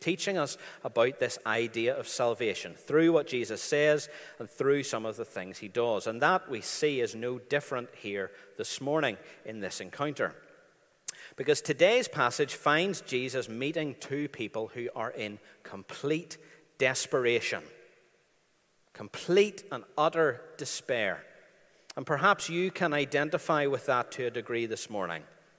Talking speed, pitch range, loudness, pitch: 145 wpm, 125-190 Hz, -30 LUFS, 150 Hz